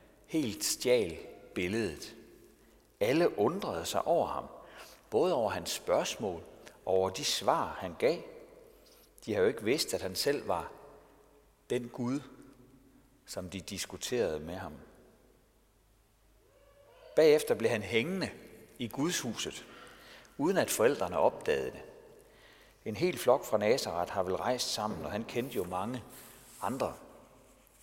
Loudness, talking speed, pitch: -32 LUFS, 130 wpm, 160 Hz